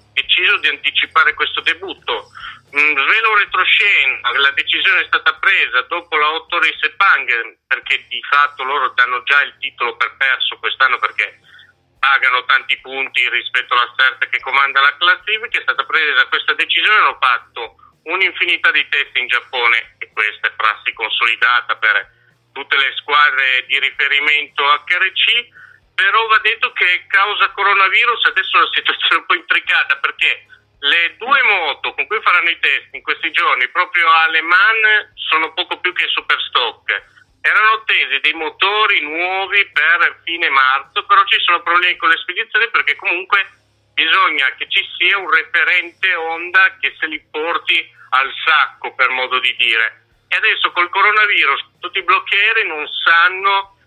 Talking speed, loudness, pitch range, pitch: 155 wpm, -14 LUFS, 150-210 Hz, 180 Hz